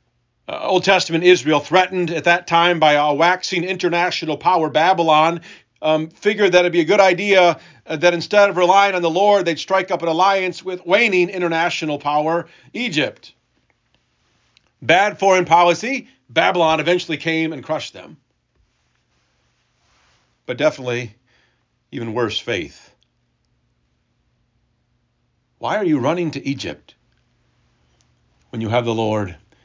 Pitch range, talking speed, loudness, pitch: 140-180 Hz, 130 wpm, -17 LUFS, 165 Hz